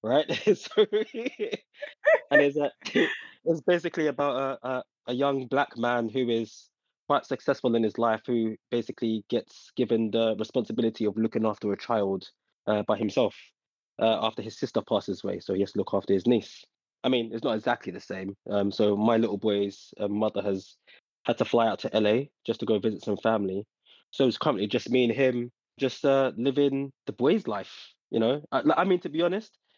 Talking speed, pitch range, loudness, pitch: 195 wpm, 110-140 Hz, -27 LUFS, 120 Hz